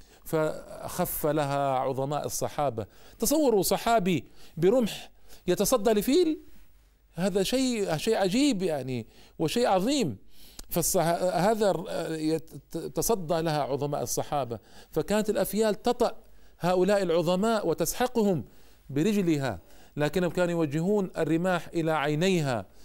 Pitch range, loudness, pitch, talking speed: 150-205 Hz, -27 LUFS, 170 Hz, 90 wpm